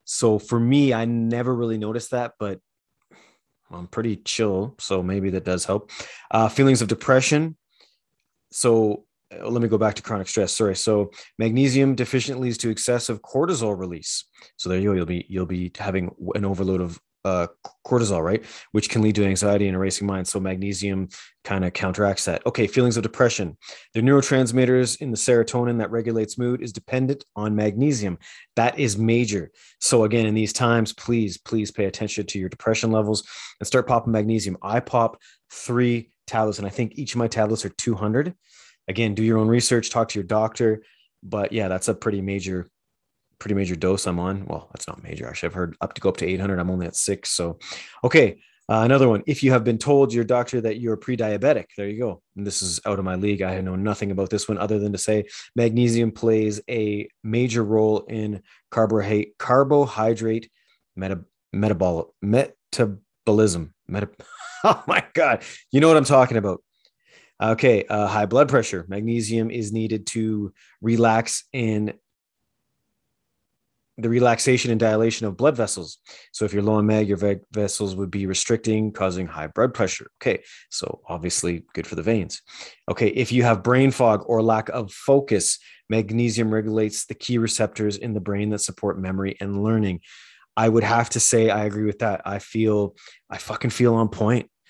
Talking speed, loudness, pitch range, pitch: 180 wpm, -22 LUFS, 100-115 Hz, 110 Hz